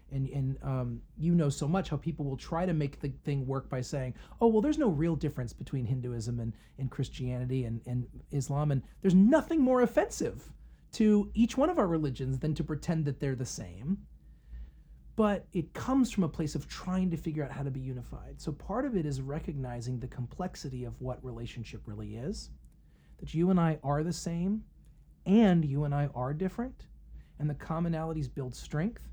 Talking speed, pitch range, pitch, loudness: 200 wpm, 130-180 Hz, 145 Hz, -32 LUFS